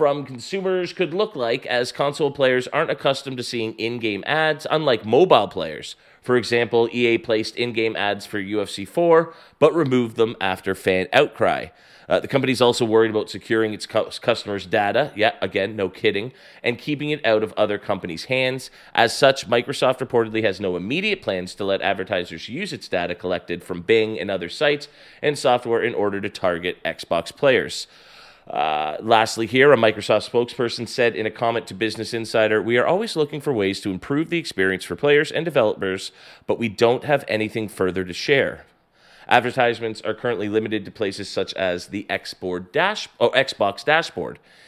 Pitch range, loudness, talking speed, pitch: 105-130 Hz, -21 LUFS, 175 wpm, 115 Hz